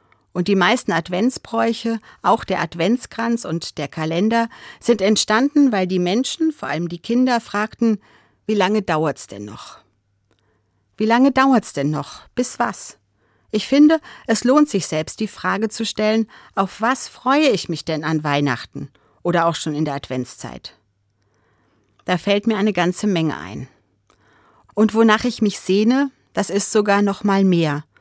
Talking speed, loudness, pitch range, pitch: 160 wpm, -19 LUFS, 155-230 Hz, 200 Hz